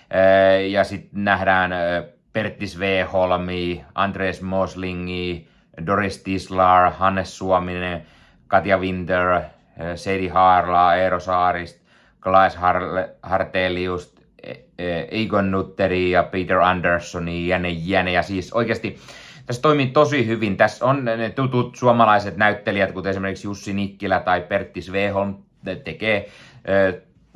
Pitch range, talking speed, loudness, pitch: 90-100 Hz, 105 wpm, -20 LUFS, 95 Hz